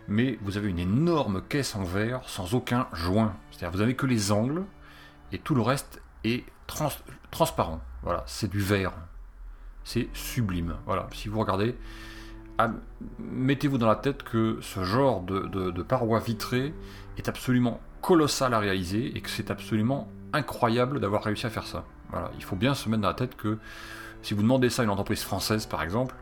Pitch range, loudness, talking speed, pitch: 100-125 Hz, -28 LUFS, 190 wpm, 110 Hz